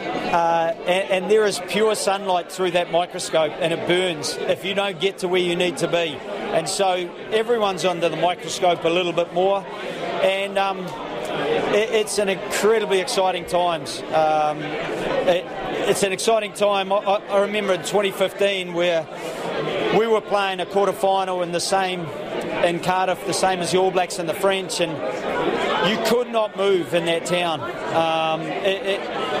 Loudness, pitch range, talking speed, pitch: -21 LUFS, 175-200 Hz, 170 wpm, 185 Hz